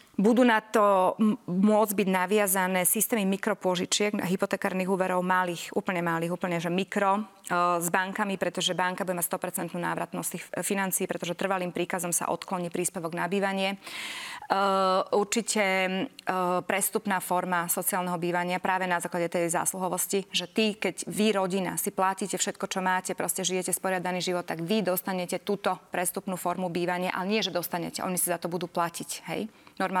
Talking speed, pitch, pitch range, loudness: 160 wpm, 185 Hz, 180-195 Hz, -28 LUFS